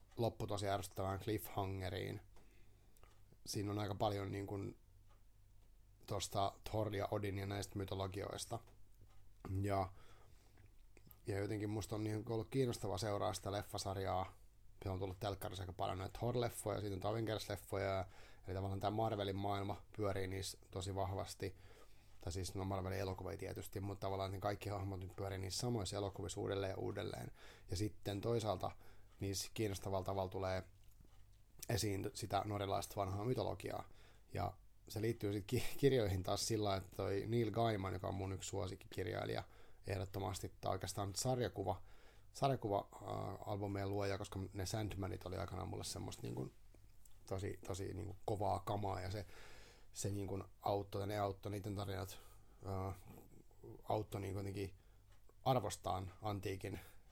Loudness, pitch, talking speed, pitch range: -43 LUFS, 100 Hz, 135 wpm, 95-105 Hz